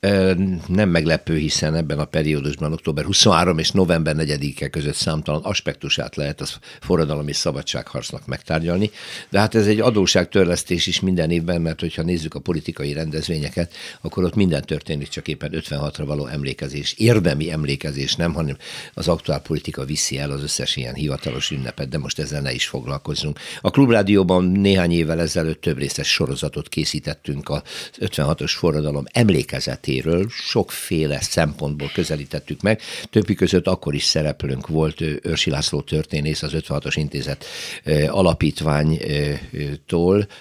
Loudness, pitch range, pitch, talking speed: -21 LUFS, 75-90 Hz, 80 Hz, 140 wpm